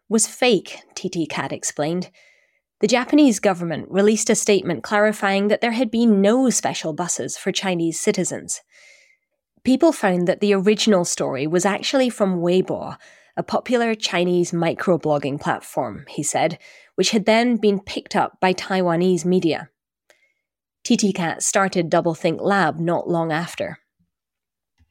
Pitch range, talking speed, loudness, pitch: 170-215 Hz, 135 wpm, -20 LUFS, 185 Hz